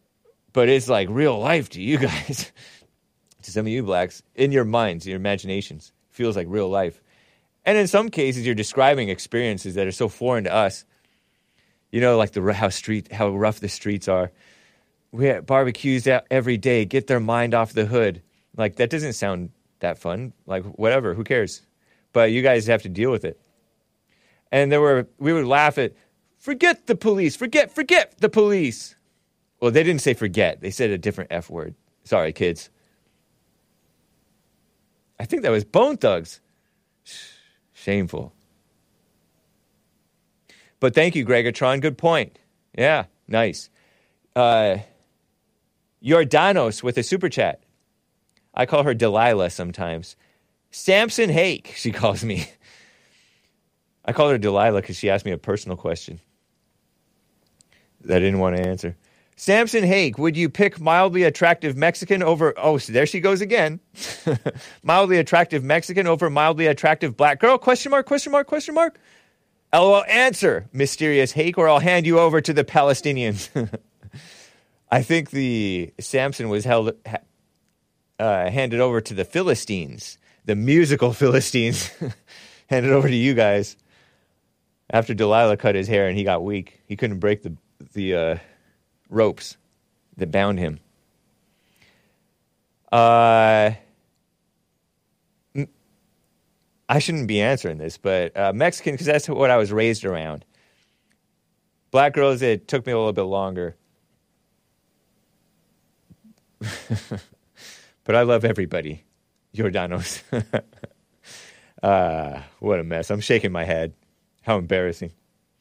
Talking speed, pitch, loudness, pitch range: 140 wpm, 120 Hz, -20 LUFS, 100-155 Hz